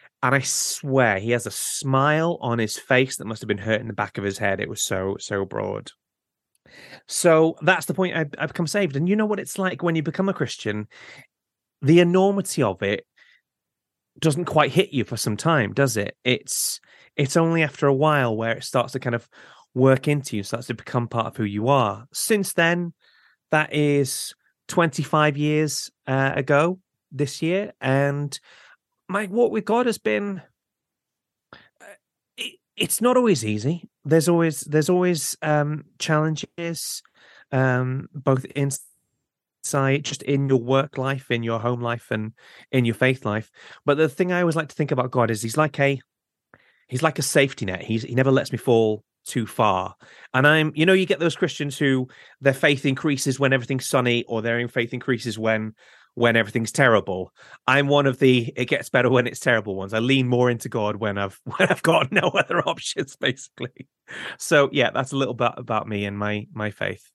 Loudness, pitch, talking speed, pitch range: -22 LUFS, 135 Hz, 190 wpm, 120-160 Hz